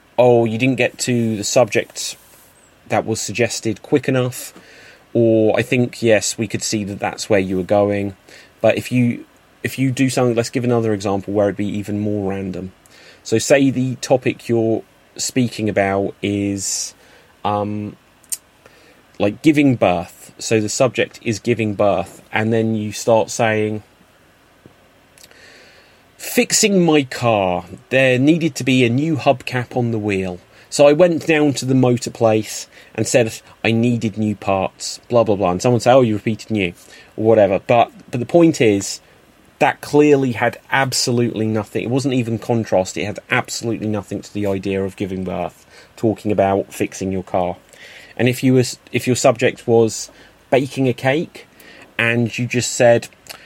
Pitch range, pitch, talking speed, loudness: 100-125 Hz, 115 Hz, 165 wpm, -18 LUFS